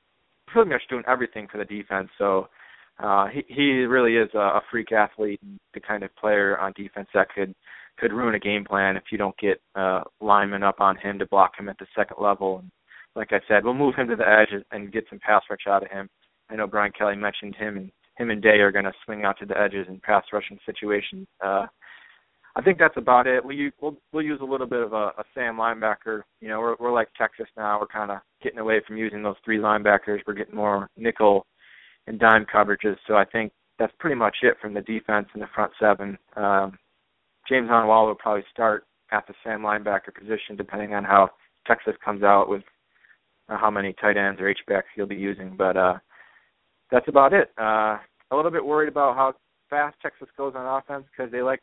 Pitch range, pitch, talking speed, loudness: 100-115 Hz, 105 Hz, 220 wpm, -23 LUFS